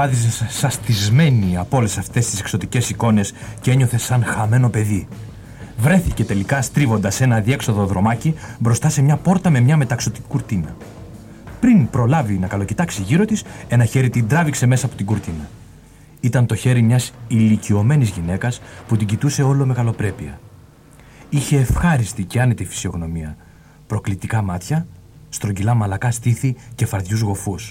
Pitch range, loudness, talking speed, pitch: 105-130 Hz, -18 LUFS, 145 wpm, 115 Hz